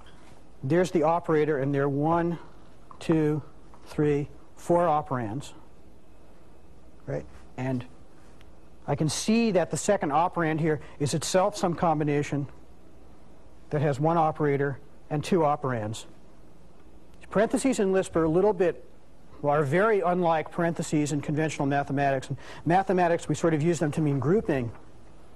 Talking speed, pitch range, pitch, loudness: 135 wpm, 130-170 Hz, 150 Hz, -26 LUFS